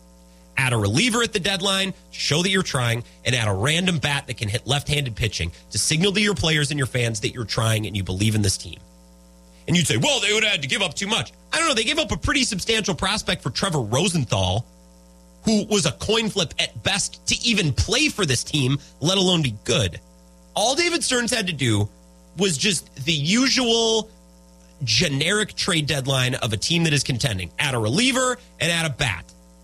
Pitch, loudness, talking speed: 140 Hz, -21 LUFS, 220 wpm